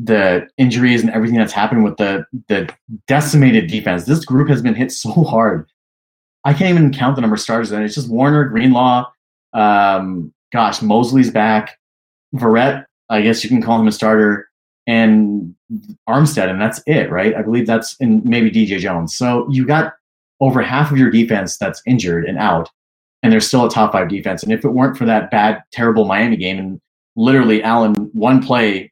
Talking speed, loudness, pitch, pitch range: 190 wpm, -14 LUFS, 115 Hz, 105-130 Hz